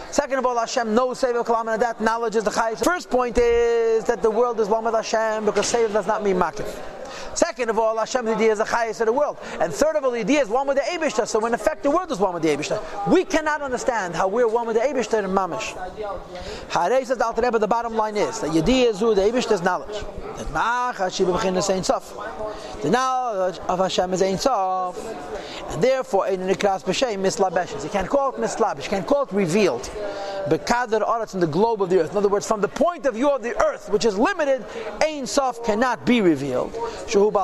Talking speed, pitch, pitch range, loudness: 210 wpm, 225 Hz, 200-255 Hz, -22 LUFS